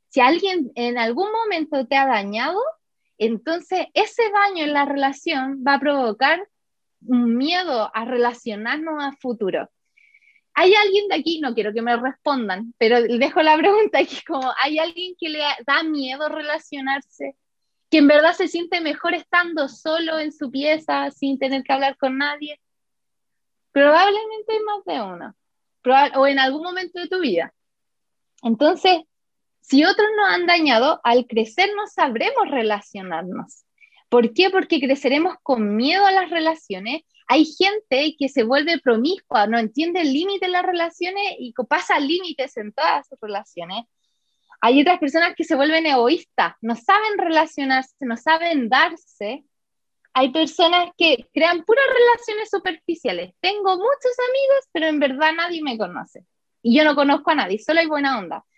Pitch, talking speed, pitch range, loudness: 300 Hz, 160 wpm, 260-355 Hz, -19 LUFS